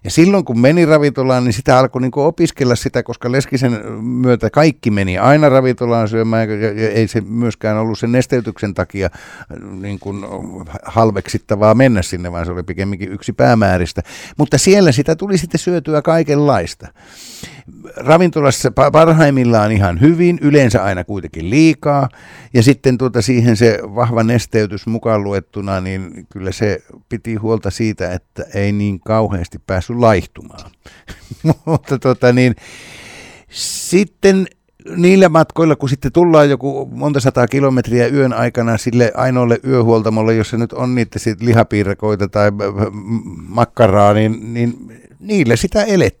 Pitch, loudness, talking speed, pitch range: 120 Hz, -14 LUFS, 135 wpm, 105-135 Hz